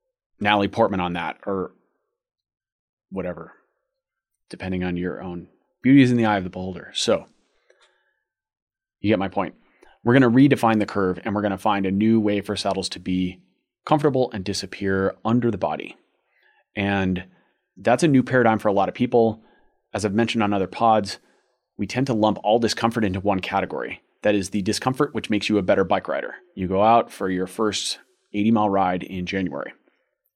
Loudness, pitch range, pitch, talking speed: -22 LUFS, 95-115 Hz, 105 Hz, 185 wpm